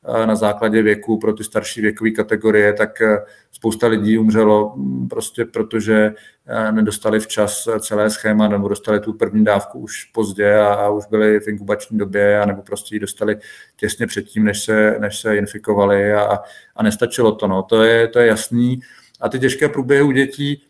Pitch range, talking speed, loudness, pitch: 105-110 Hz, 170 wpm, -17 LUFS, 105 Hz